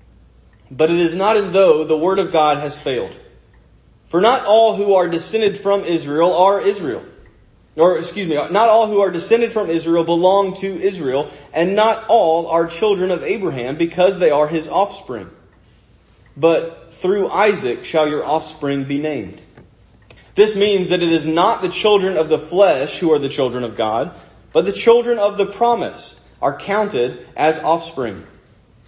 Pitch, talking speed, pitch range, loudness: 170 Hz, 170 wpm, 155-200 Hz, -17 LUFS